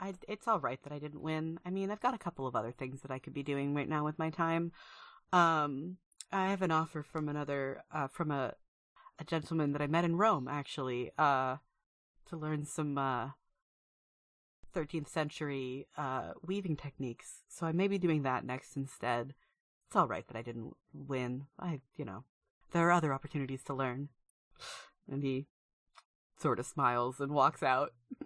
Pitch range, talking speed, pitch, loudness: 130-165 Hz, 185 wpm, 145 Hz, -36 LUFS